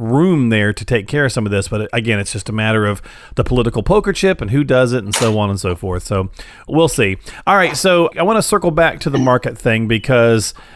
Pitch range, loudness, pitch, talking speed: 105-145 Hz, -15 LUFS, 120 Hz, 255 wpm